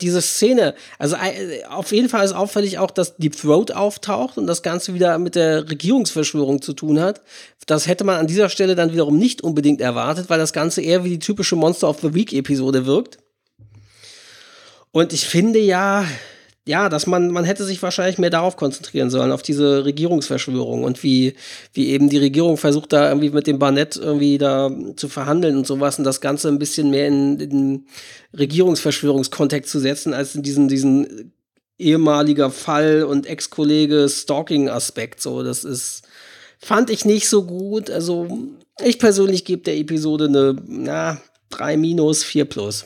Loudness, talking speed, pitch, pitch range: -18 LUFS, 170 wpm, 155 Hz, 140-180 Hz